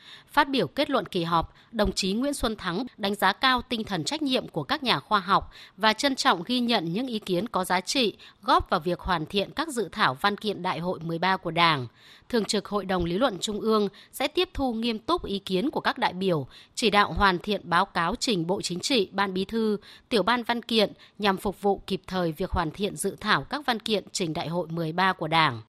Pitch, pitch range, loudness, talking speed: 200 Hz, 180-230 Hz, -26 LUFS, 245 wpm